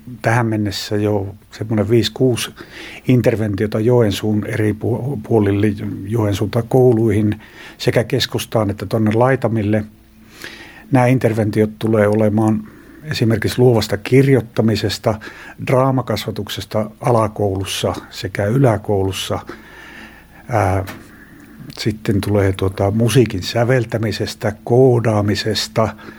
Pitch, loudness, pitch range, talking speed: 110 Hz, -17 LUFS, 105-120 Hz, 75 wpm